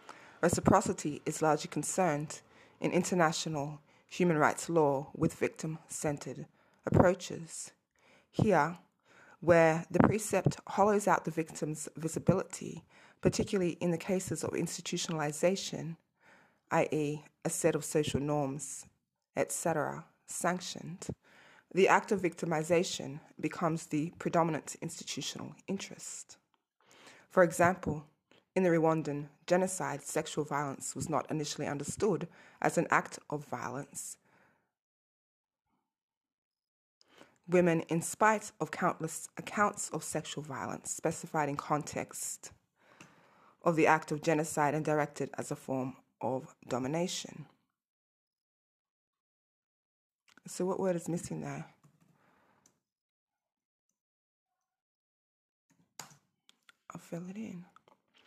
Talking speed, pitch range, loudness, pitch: 100 wpm, 150-180 Hz, -33 LUFS, 160 Hz